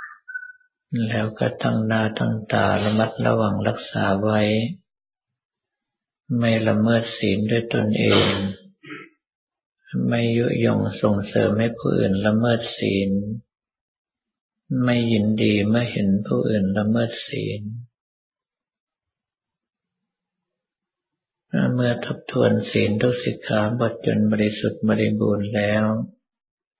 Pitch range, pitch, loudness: 105-120 Hz, 110 Hz, -21 LUFS